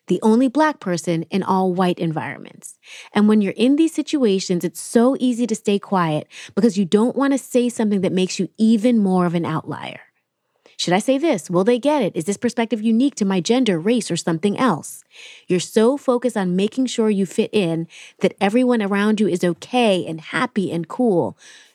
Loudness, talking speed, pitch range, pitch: -19 LUFS, 200 wpm, 180-245 Hz, 210 Hz